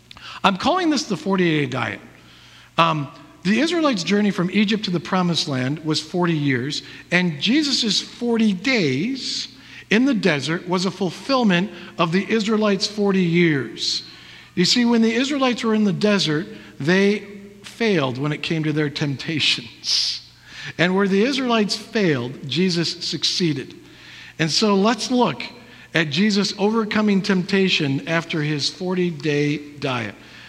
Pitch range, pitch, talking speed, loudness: 155-210 Hz, 185 Hz, 140 wpm, -20 LUFS